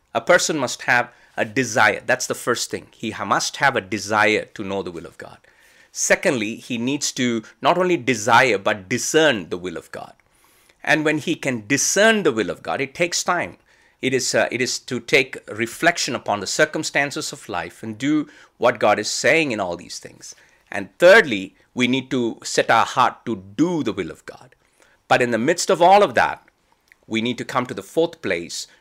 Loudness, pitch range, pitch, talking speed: -20 LUFS, 110-150 Hz, 130 Hz, 205 wpm